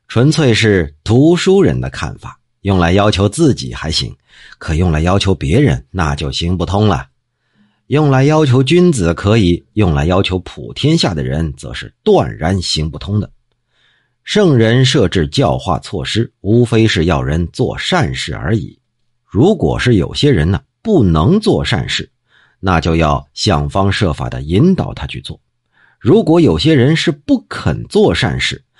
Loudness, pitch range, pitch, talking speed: -13 LUFS, 85-130 Hz, 105 Hz, 225 characters per minute